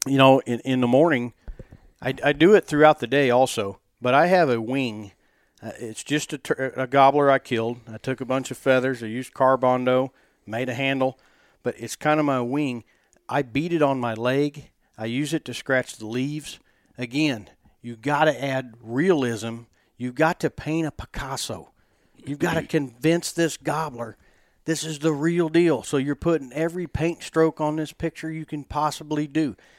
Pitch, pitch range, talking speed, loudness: 135 Hz, 125-155 Hz, 190 wpm, -23 LUFS